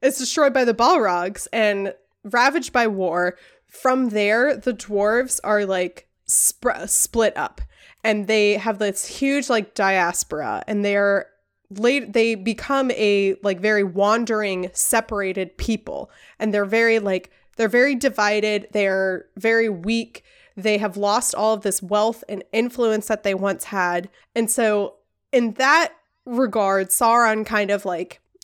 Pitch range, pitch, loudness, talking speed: 200-235 Hz, 215 Hz, -20 LUFS, 145 wpm